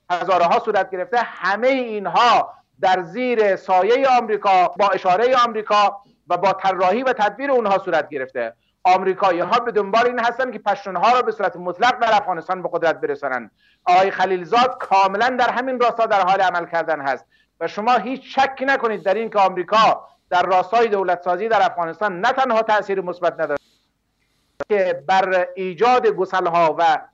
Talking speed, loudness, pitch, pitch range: 160 wpm, -19 LUFS, 200 Hz, 185-240 Hz